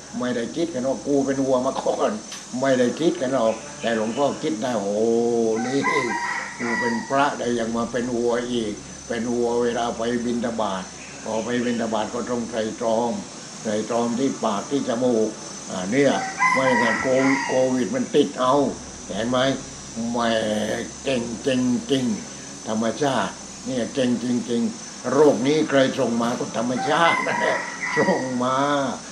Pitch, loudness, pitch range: 125 Hz, -23 LUFS, 115-140 Hz